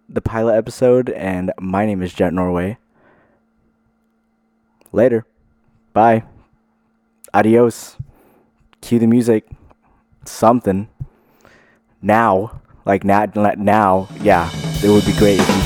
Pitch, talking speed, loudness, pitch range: 110 Hz, 105 wpm, -16 LUFS, 100-120 Hz